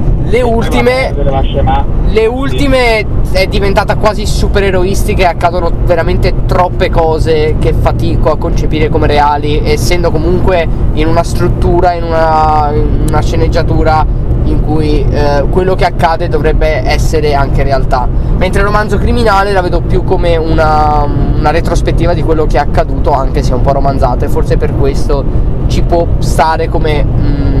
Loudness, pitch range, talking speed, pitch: -11 LUFS, 130-160 Hz, 150 wpm, 150 Hz